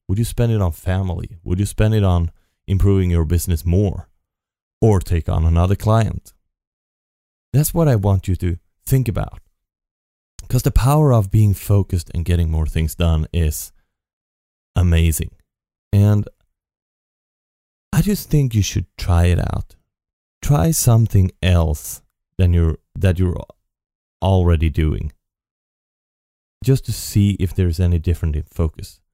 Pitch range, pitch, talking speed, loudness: 80-100 Hz, 90 Hz, 140 wpm, -18 LUFS